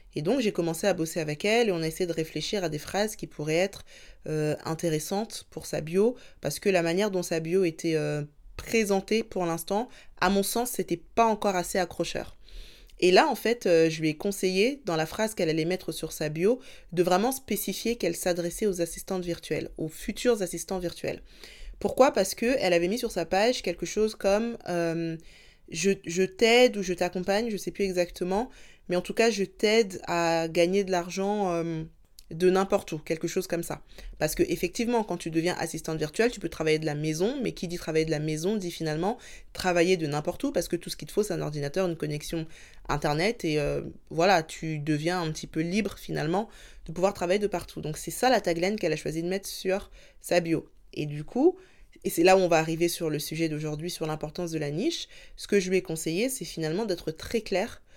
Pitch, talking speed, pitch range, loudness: 180 Hz, 225 wpm, 165-200 Hz, -28 LUFS